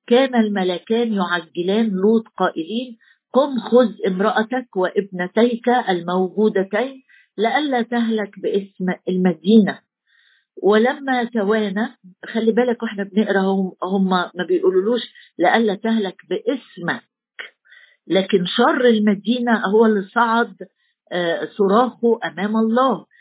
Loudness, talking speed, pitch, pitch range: -19 LUFS, 90 wpm, 220 Hz, 190-240 Hz